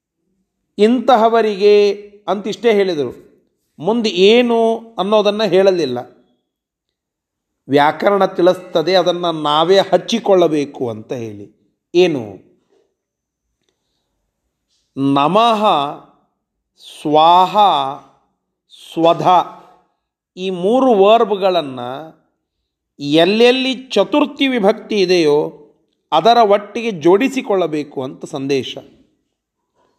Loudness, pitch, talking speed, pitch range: -14 LUFS, 190 Hz, 60 wpm, 155-220 Hz